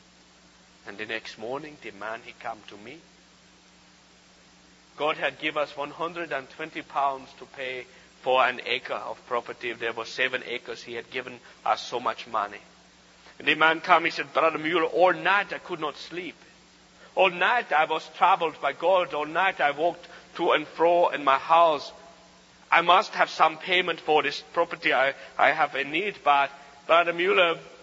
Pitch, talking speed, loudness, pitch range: 155 Hz, 175 wpm, -25 LUFS, 140-170 Hz